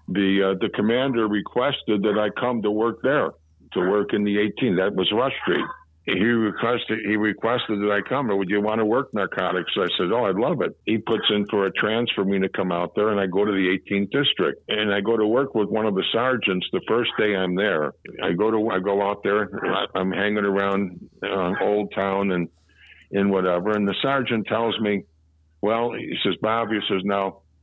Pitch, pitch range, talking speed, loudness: 105 Hz, 95-110 Hz, 220 wpm, -23 LUFS